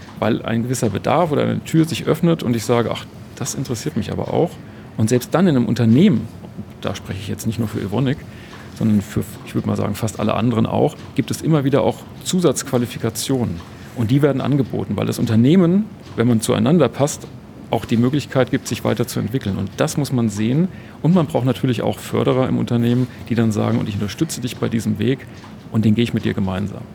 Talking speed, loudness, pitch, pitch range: 210 wpm, -19 LUFS, 120 Hz, 110-135 Hz